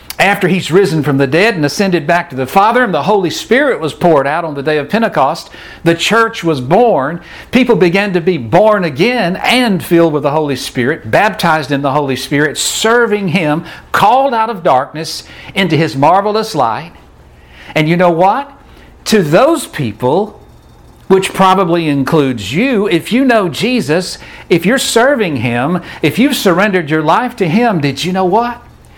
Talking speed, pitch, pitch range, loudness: 175 wpm, 180 Hz, 150-215 Hz, -12 LUFS